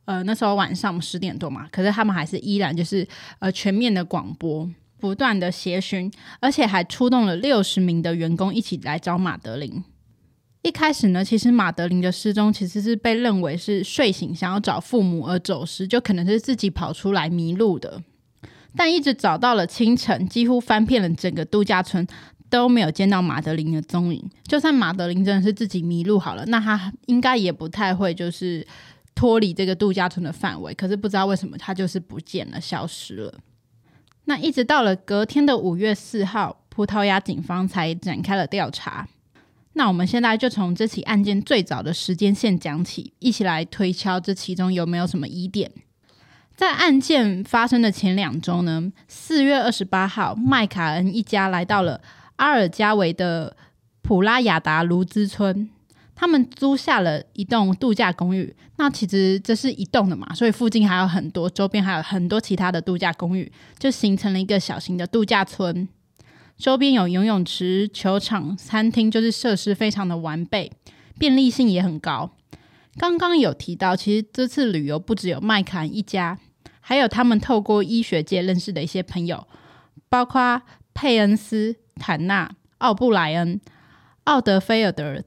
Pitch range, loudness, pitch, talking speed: 175-225 Hz, -21 LUFS, 195 Hz, 275 characters per minute